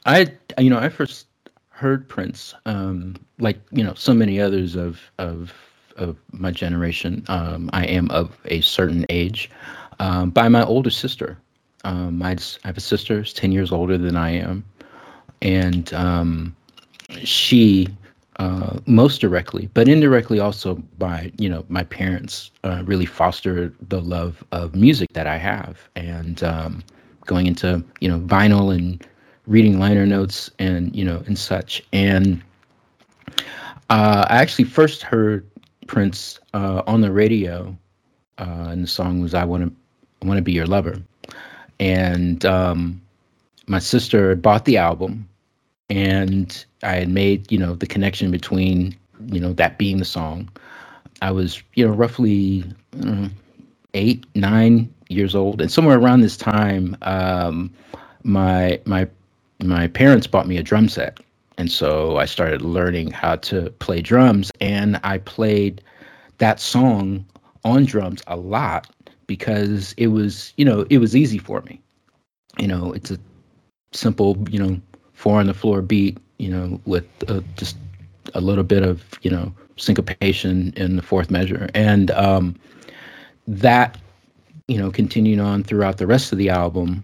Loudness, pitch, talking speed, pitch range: -19 LUFS, 95 Hz, 155 wpm, 90-105 Hz